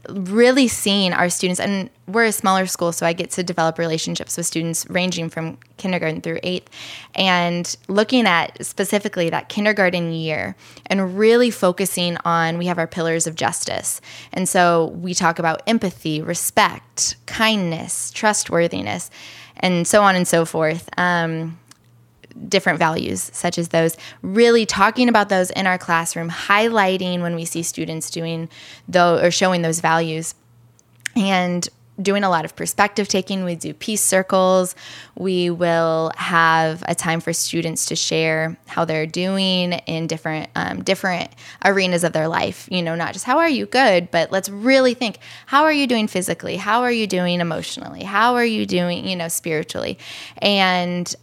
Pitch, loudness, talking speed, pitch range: 175 Hz, -19 LUFS, 165 wpm, 165-195 Hz